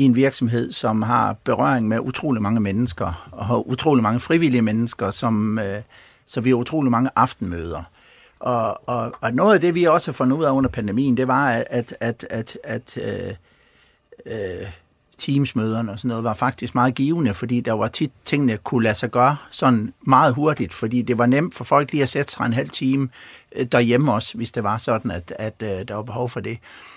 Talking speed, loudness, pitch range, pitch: 205 wpm, -21 LUFS, 115-135 Hz, 120 Hz